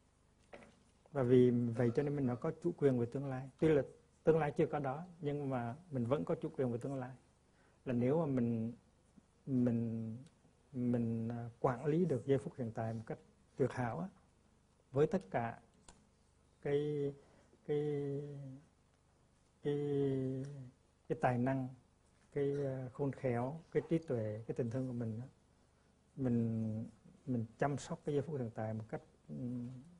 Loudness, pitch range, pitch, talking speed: -38 LUFS, 115-145 Hz, 130 Hz, 155 wpm